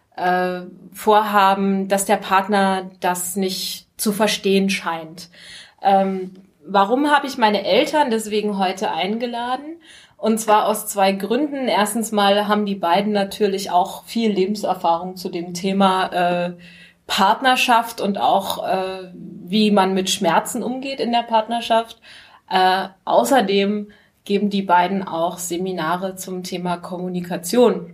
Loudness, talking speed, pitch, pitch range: -19 LUFS, 115 wpm, 195 Hz, 185-215 Hz